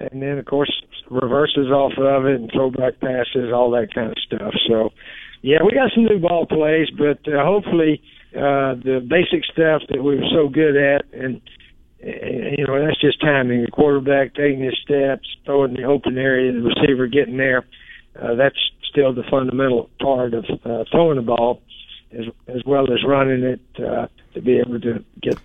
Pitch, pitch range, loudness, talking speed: 135 Hz, 125-145 Hz, -18 LUFS, 190 wpm